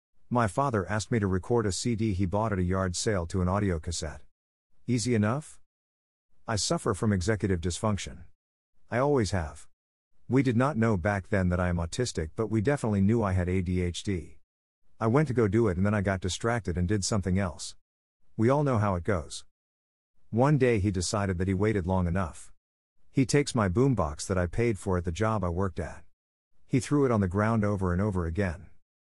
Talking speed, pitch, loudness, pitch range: 205 wpm, 100 Hz, -28 LUFS, 85-110 Hz